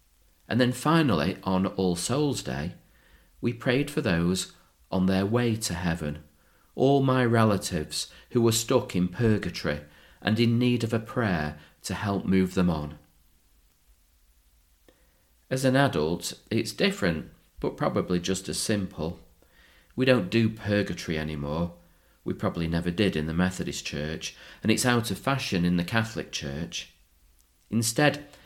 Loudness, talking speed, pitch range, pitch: -27 LUFS, 145 wpm, 80-115 Hz, 90 Hz